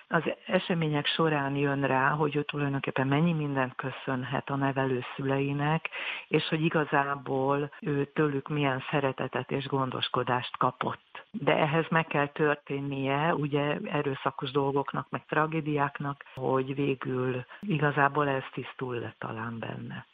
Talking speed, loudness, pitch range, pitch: 125 wpm, -29 LUFS, 135-150 Hz, 140 Hz